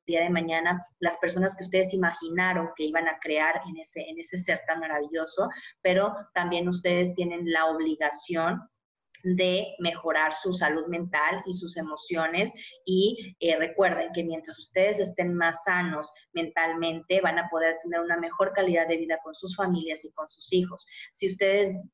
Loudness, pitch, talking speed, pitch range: -27 LUFS, 170 Hz, 165 wpm, 160-185 Hz